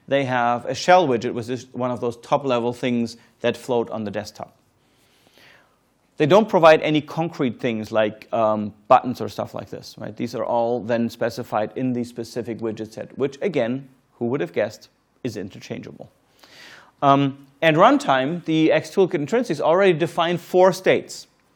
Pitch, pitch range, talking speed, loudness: 125 Hz, 120-155 Hz, 165 wpm, -21 LUFS